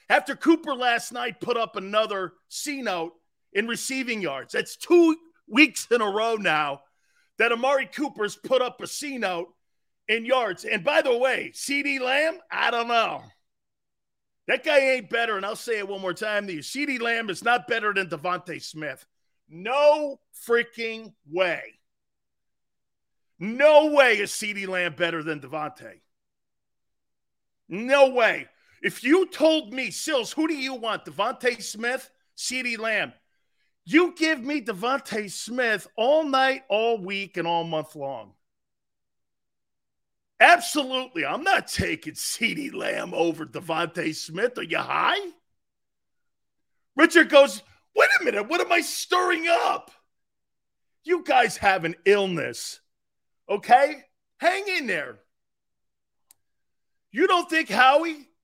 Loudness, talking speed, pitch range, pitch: -23 LUFS, 135 wpm, 195-295 Hz, 240 Hz